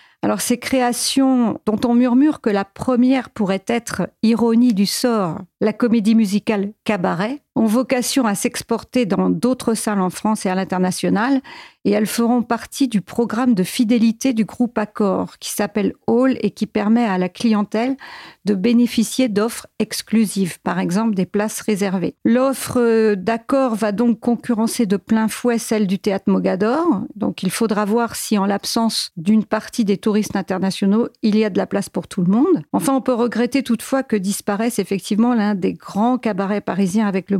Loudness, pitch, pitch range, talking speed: -19 LUFS, 220 Hz, 205-240 Hz, 175 wpm